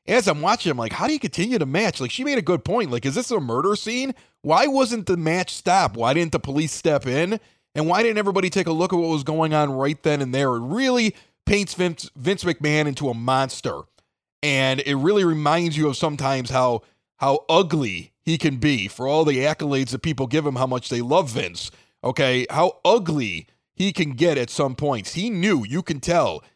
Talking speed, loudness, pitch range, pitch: 225 wpm, -22 LUFS, 135-185 Hz, 160 Hz